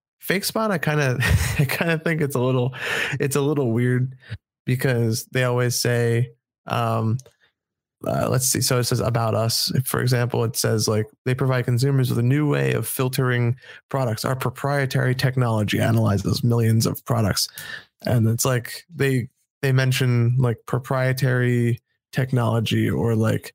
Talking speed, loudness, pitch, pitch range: 160 wpm, -22 LUFS, 125 Hz, 115-135 Hz